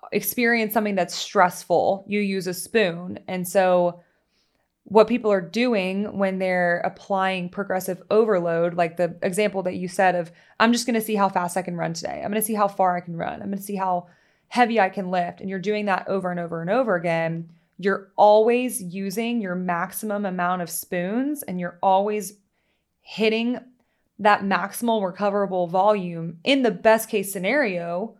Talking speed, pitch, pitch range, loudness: 185 wpm, 195 Hz, 180-215 Hz, -23 LUFS